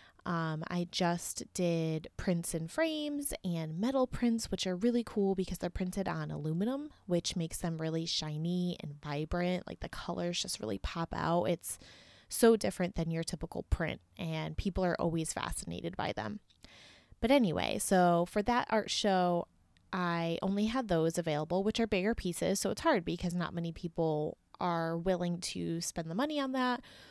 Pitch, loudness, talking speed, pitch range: 175 Hz, -34 LUFS, 175 wpm, 165-200 Hz